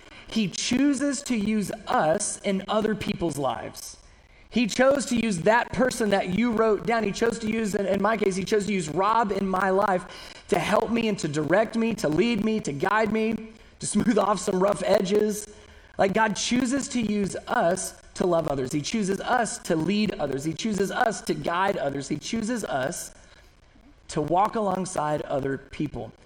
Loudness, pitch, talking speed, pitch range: -25 LUFS, 210 Hz, 185 wpm, 185-225 Hz